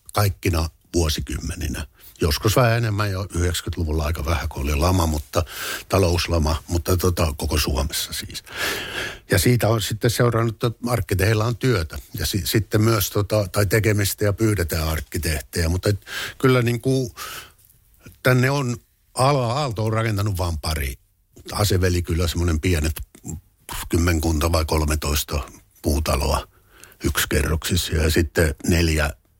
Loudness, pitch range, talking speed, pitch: -22 LUFS, 80-110 Hz, 120 wpm, 90 Hz